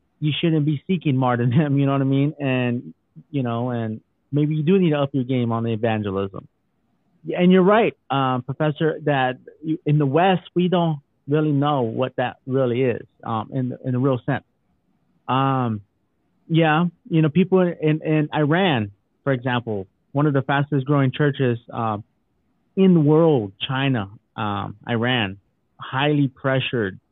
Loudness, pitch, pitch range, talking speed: -21 LUFS, 135 Hz, 120-155 Hz, 165 wpm